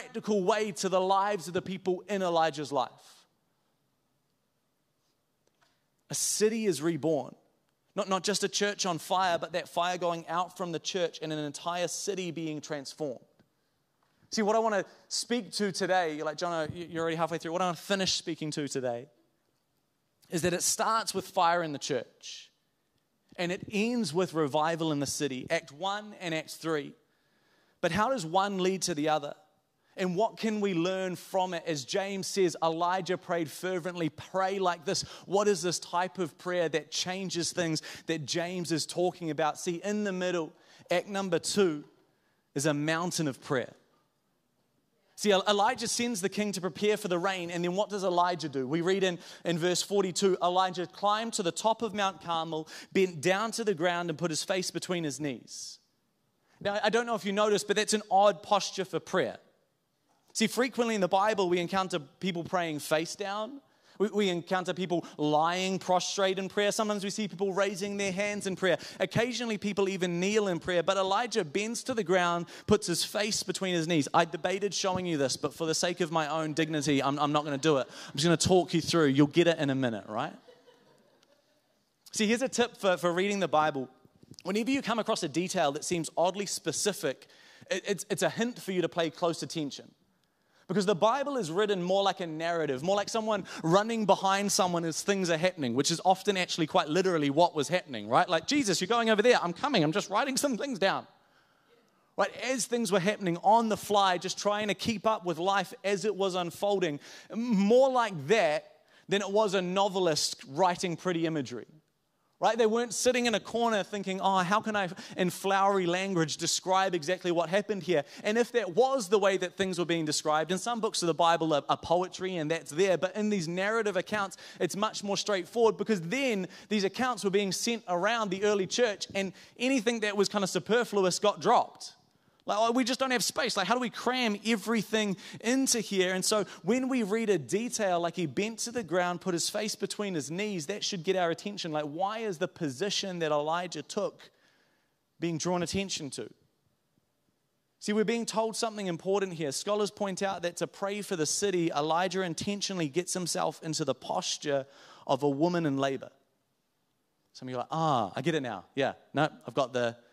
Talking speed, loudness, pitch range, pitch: 200 wpm, -30 LUFS, 165-205 Hz, 185 Hz